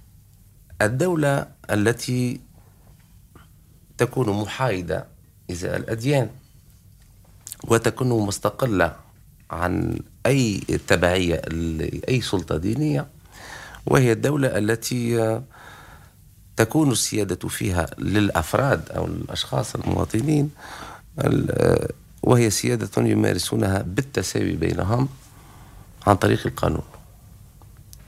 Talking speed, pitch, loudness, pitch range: 70 wpm, 110 Hz, -22 LUFS, 100-125 Hz